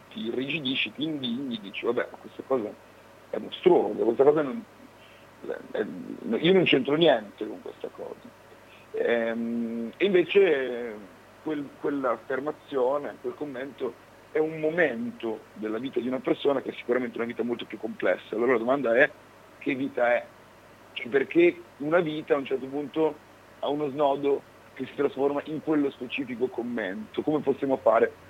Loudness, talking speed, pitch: -27 LUFS, 145 wpm, 155 Hz